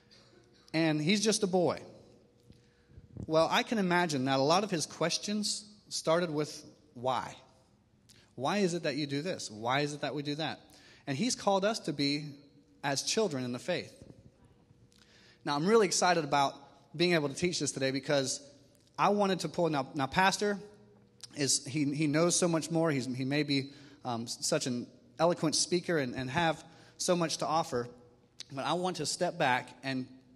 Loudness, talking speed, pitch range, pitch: -31 LUFS, 180 wpm, 135-175 Hz, 150 Hz